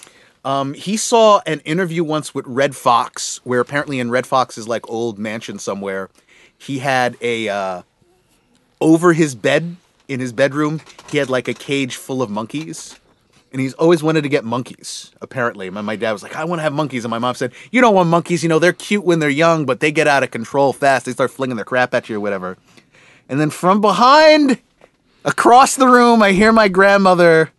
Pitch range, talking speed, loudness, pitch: 125-170 Hz, 210 wpm, -16 LUFS, 140 Hz